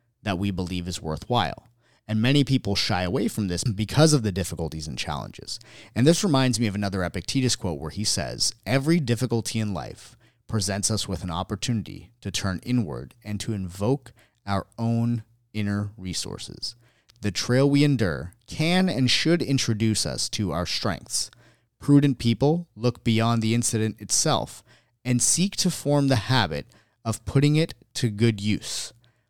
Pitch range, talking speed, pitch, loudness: 100-125 Hz, 160 wpm, 115 Hz, -25 LUFS